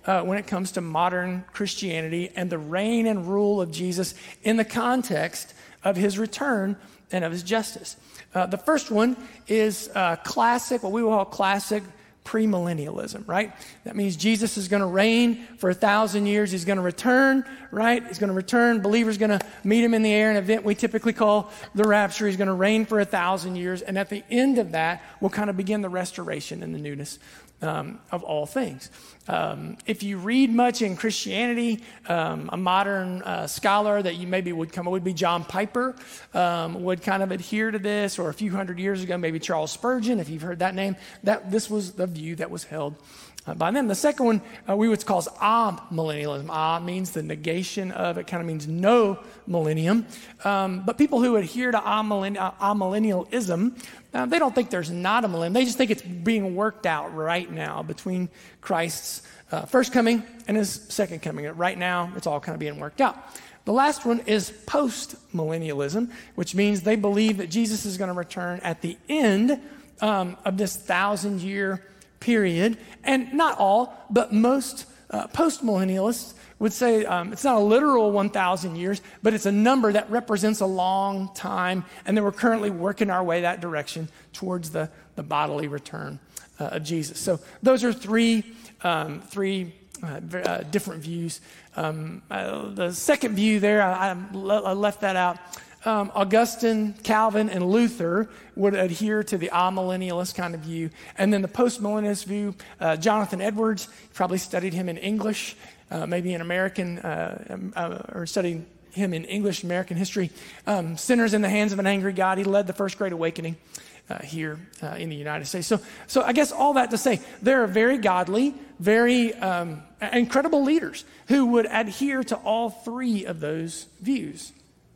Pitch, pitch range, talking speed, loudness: 200 Hz, 180-225 Hz, 185 wpm, -25 LUFS